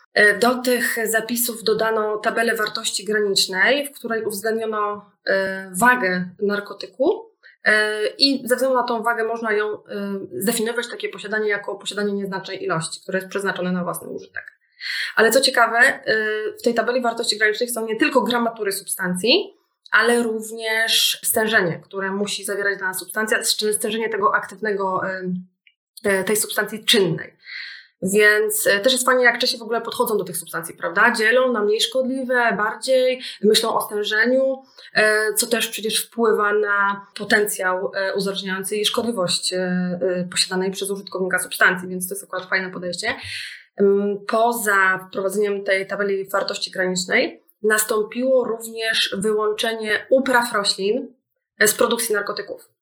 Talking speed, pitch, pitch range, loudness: 130 wpm, 215 Hz, 195-235 Hz, -20 LUFS